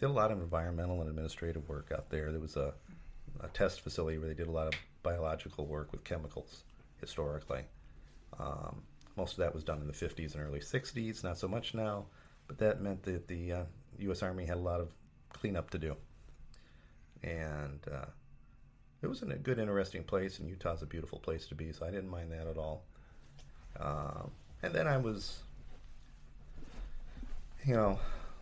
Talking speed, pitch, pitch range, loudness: 185 wpm, 80 Hz, 75-95 Hz, -39 LUFS